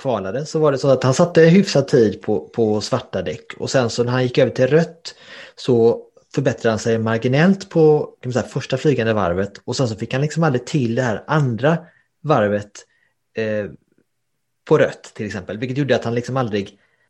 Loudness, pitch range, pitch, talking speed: -19 LUFS, 115-150 Hz, 130 Hz, 205 wpm